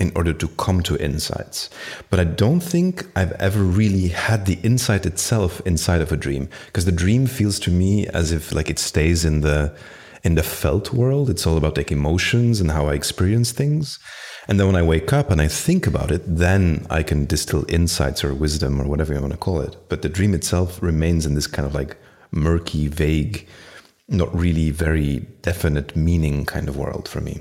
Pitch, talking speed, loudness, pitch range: 85 Hz, 210 wpm, -20 LUFS, 75-100 Hz